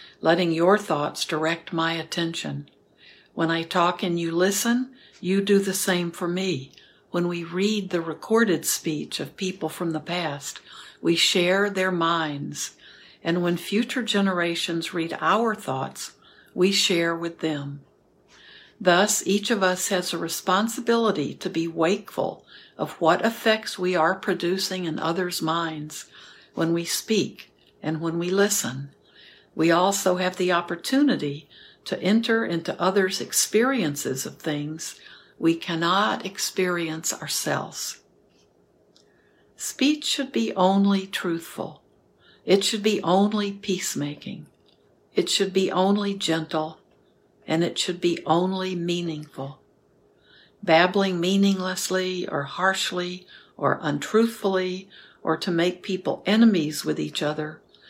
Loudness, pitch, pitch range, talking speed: -24 LUFS, 180 Hz, 165-195 Hz, 125 wpm